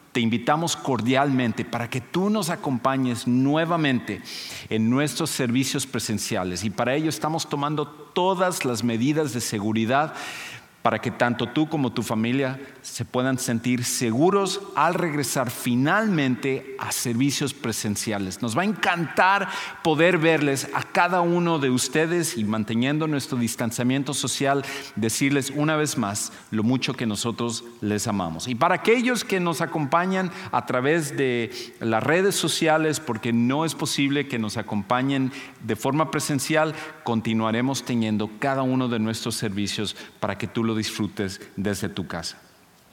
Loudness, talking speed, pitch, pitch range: -24 LUFS, 145 wpm, 130 Hz, 115-155 Hz